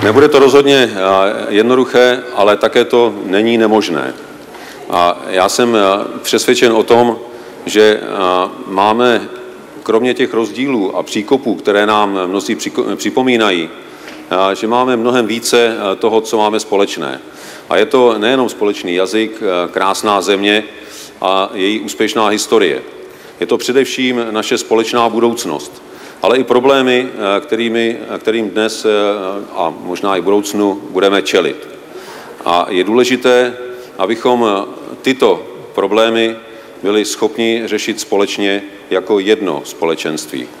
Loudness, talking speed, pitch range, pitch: -13 LUFS, 115 wpm, 100-125 Hz, 110 Hz